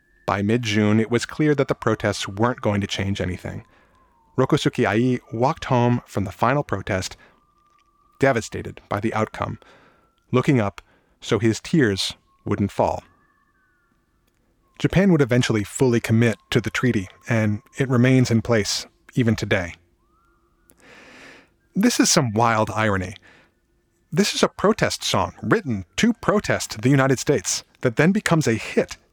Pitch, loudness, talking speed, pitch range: 115 Hz, -21 LUFS, 140 wpm, 105-135 Hz